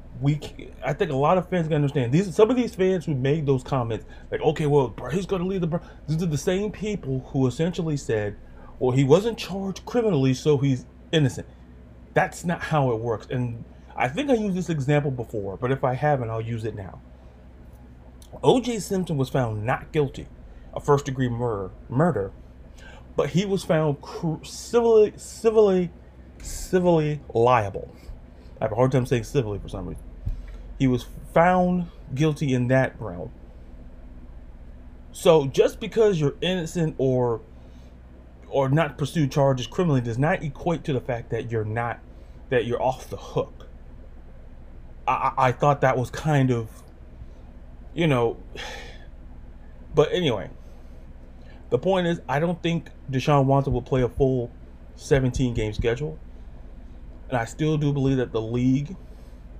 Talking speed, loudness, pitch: 160 wpm, -24 LUFS, 125 Hz